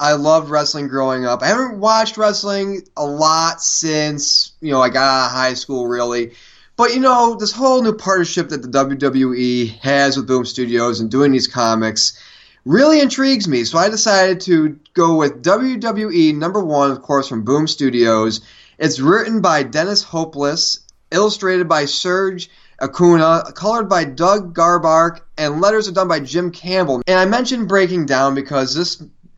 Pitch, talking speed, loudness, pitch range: 155 Hz, 170 wpm, -15 LUFS, 135-190 Hz